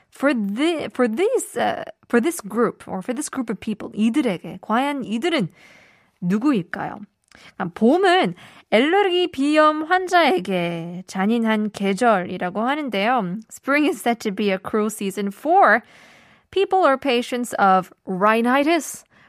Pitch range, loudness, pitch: 200-295 Hz, -20 LUFS, 235 Hz